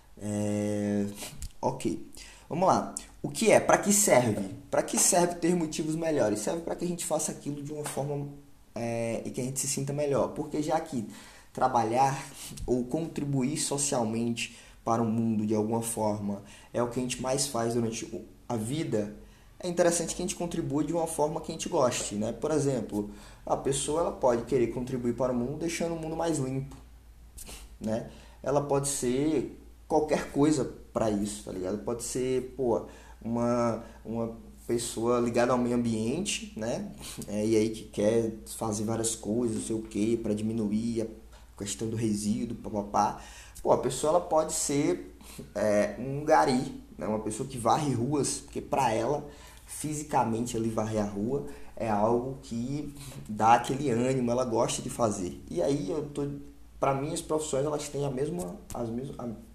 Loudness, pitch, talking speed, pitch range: -29 LUFS, 120 Hz, 175 wpm, 110-145 Hz